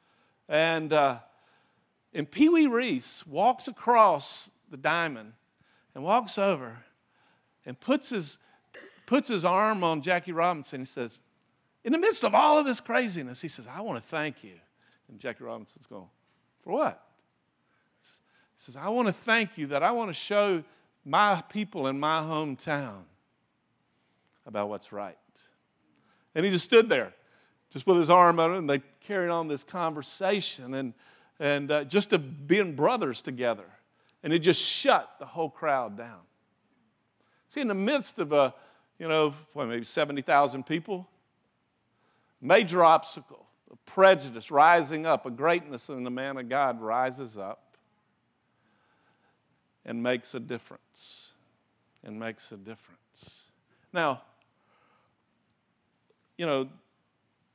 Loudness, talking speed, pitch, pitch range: -27 LUFS, 140 wpm, 155 Hz, 135-190 Hz